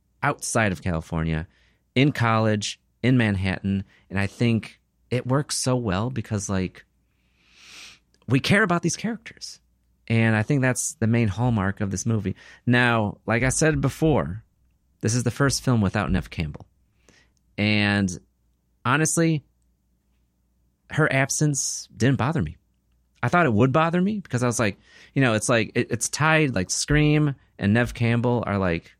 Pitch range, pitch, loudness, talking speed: 95-130 Hz, 110 Hz, -23 LUFS, 155 wpm